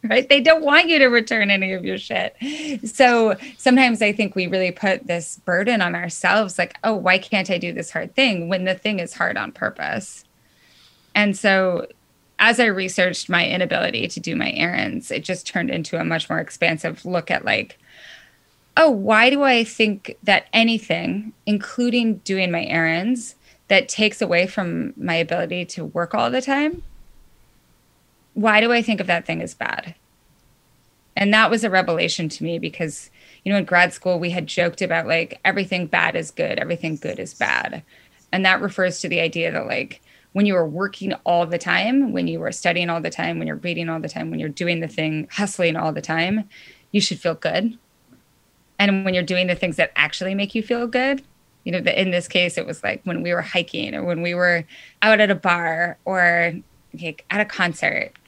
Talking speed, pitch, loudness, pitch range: 200 wpm, 190 Hz, -20 LUFS, 175-220 Hz